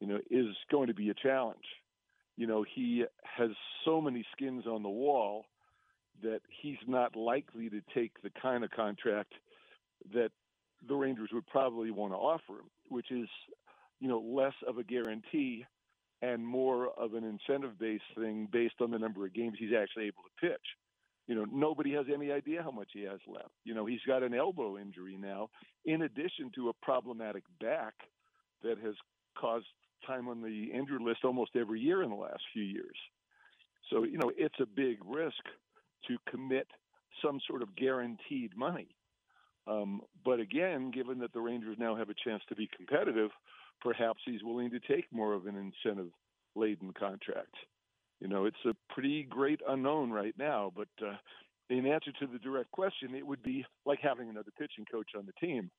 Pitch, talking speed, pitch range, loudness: 120 Hz, 180 wpm, 110-135 Hz, -37 LUFS